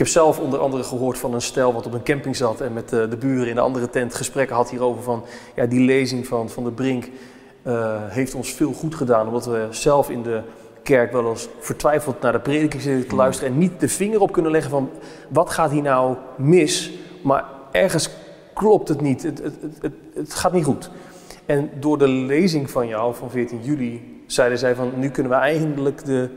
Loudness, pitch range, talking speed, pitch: -21 LUFS, 120-145 Hz, 225 wpm, 130 Hz